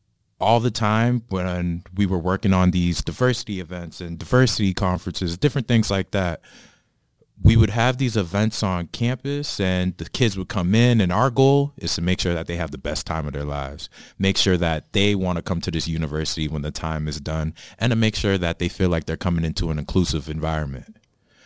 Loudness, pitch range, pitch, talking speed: -22 LUFS, 80-110 Hz, 90 Hz, 215 wpm